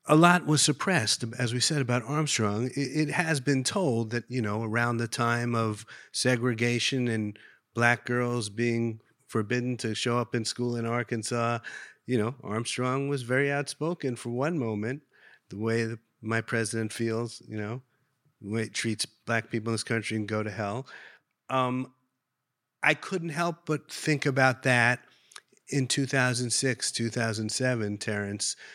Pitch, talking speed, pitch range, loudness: 120 Hz, 155 wpm, 115-135 Hz, -28 LUFS